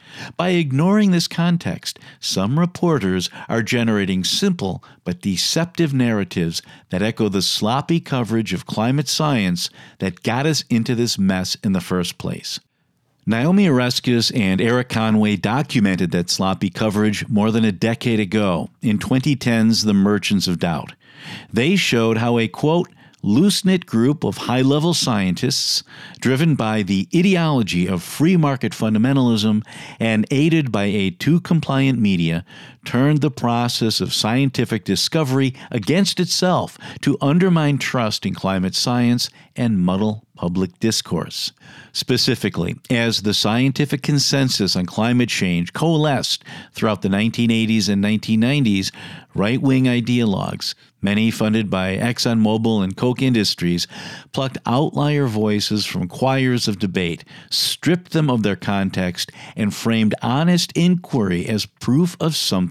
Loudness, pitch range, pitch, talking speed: -19 LUFS, 105-145 Hz, 120 Hz, 135 wpm